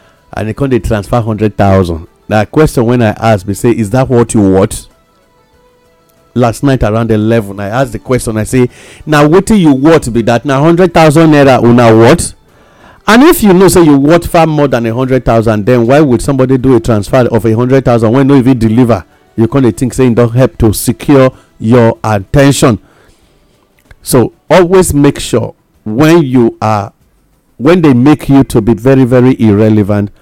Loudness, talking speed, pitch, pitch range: -8 LUFS, 200 wpm, 125 Hz, 110-140 Hz